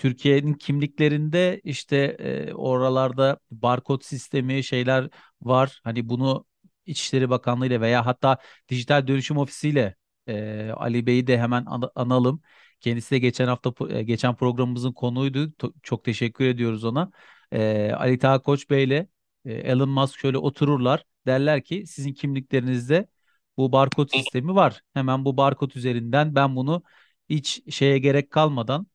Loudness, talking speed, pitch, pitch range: -23 LUFS, 140 wpm, 135 Hz, 125-145 Hz